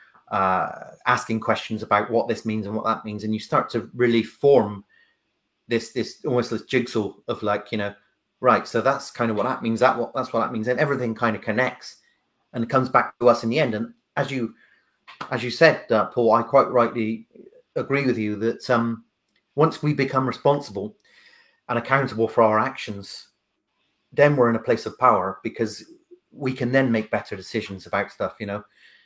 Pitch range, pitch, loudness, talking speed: 110-130 Hz, 115 Hz, -23 LUFS, 200 wpm